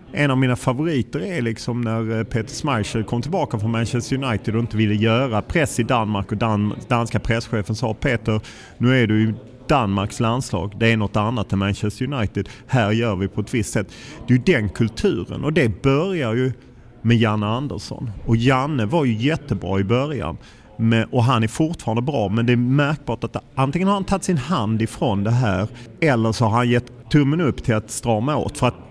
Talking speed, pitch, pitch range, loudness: 205 wpm, 115 Hz, 110-130 Hz, -21 LUFS